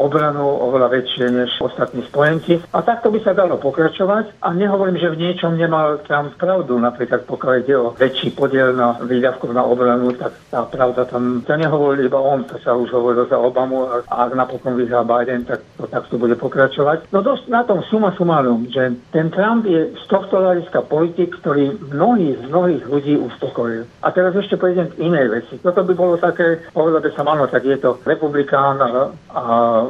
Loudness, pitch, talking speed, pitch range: -17 LUFS, 145 Hz, 190 wpm, 125-175 Hz